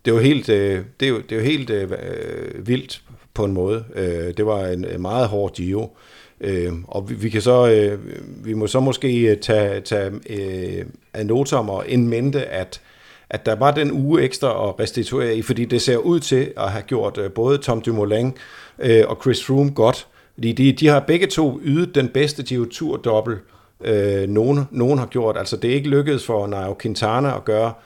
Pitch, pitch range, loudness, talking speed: 115 Hz, 105-135 Hz, -20 LUFS, 175 wpm